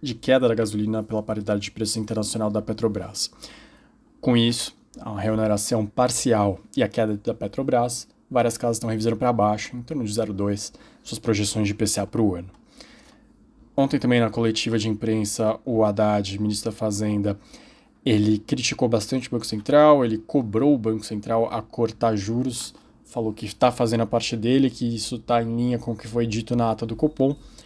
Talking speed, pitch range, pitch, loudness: 180 wpm, 105-120 Hz, 115 Hz, -23 LUFS